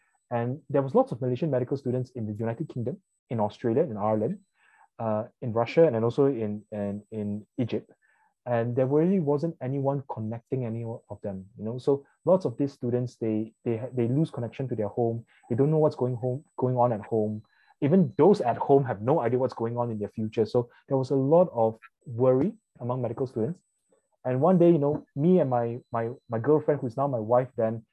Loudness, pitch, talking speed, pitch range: -27 LUFS, 125 Hz, 215 wpm, 115-140 Hz